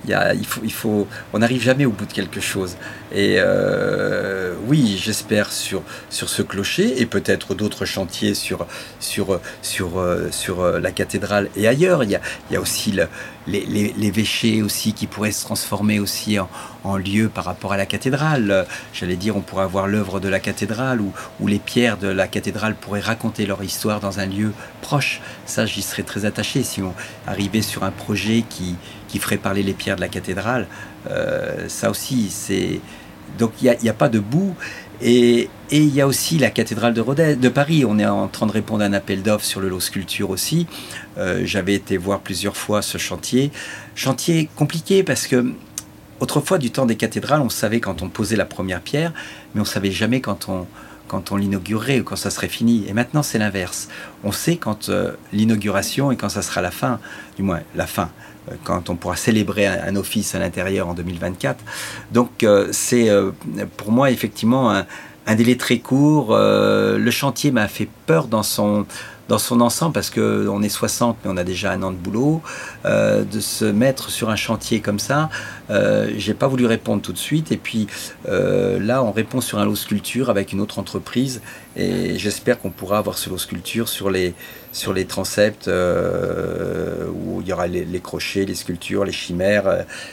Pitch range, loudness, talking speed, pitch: 100-120 Hz, -20 LUFS, 200 wpm, 105 Hz